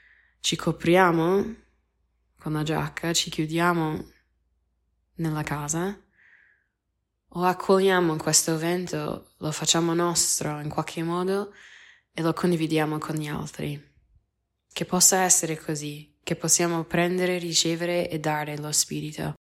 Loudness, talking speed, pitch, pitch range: -24 LUFS, 115 wpm, 165 Hz, 150-175 Hz